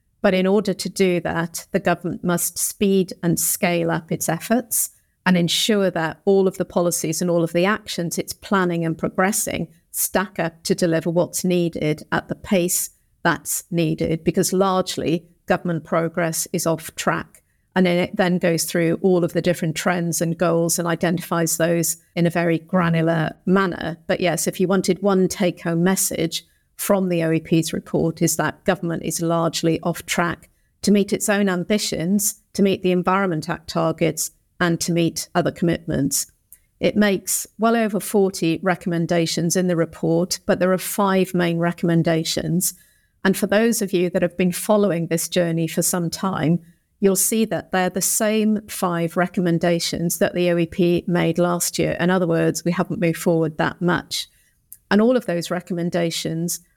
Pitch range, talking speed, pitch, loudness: 170-190 Hz, 170 wpm, 175 Hz, -21 LUFS